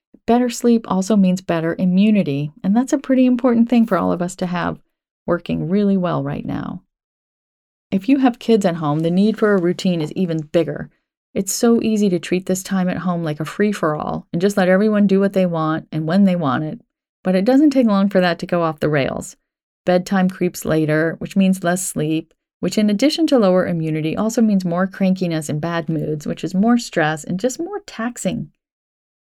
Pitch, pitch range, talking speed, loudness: 190 Hz, 170-220 Hz, 215 wpm, -18 LUFS